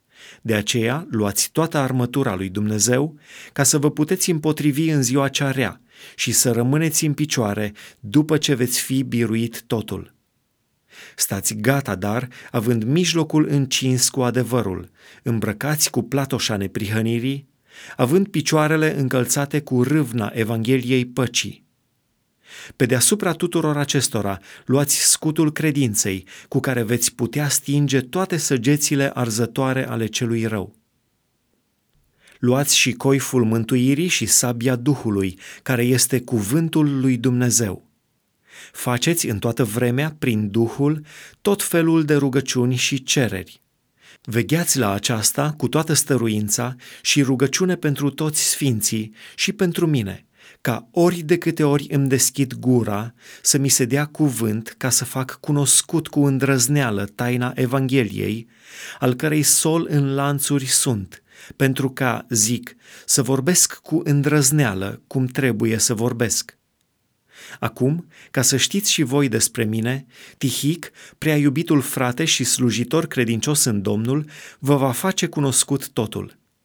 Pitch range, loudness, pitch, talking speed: 120-150 Hz, -19 LUFS, 135 Hz, 125 wpm